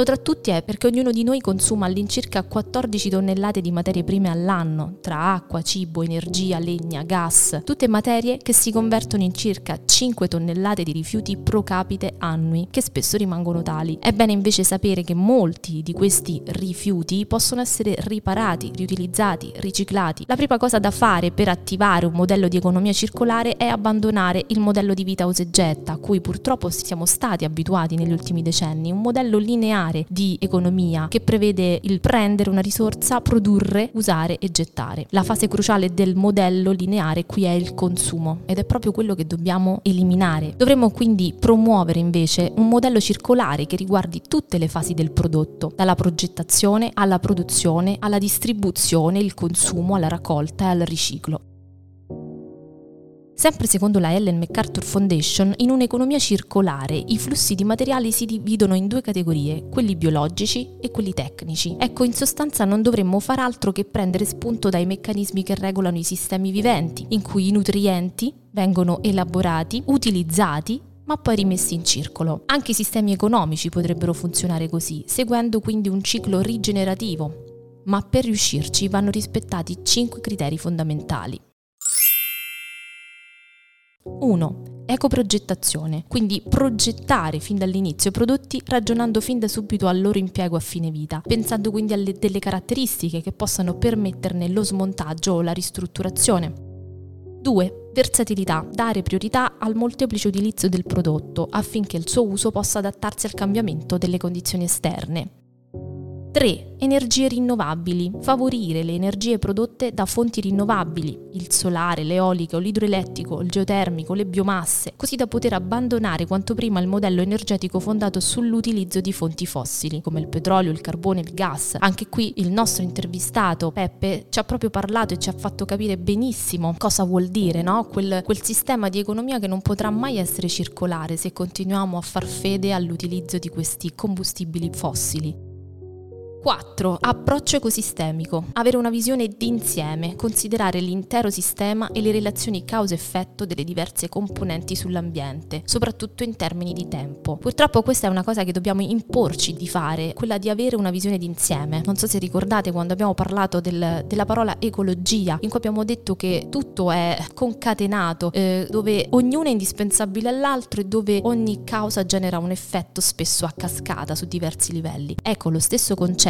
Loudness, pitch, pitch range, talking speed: -21 LUFS, 190 Hz, 170-215 Hz, 155 wpm